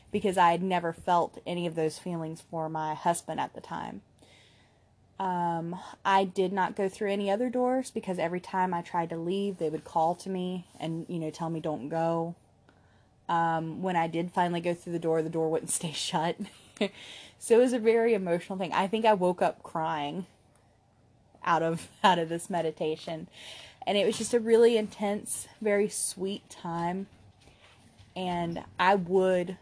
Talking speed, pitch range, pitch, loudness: 180 wpm, 160-190 Hz, 175 Hz, -29 LUFS